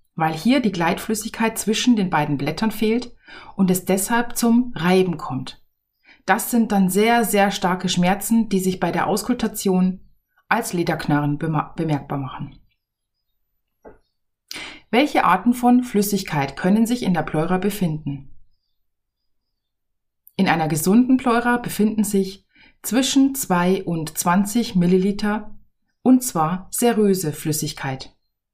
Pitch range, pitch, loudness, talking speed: 150-220 Hz, 185 Hz, -20 LUFS, 120 wpm